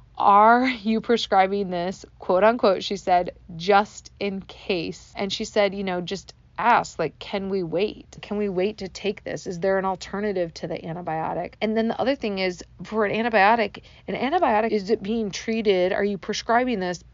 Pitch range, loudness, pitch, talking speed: 185-220 Hz, -23 LUFS, 200 Hz, 190 wpm